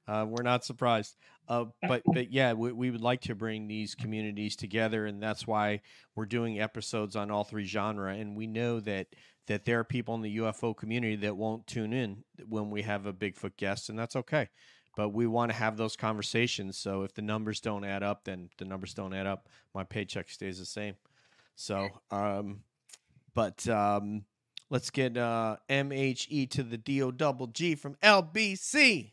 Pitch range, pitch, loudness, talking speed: 105-125 Hz, 110 Hz, -32 LUFS, 190 wpm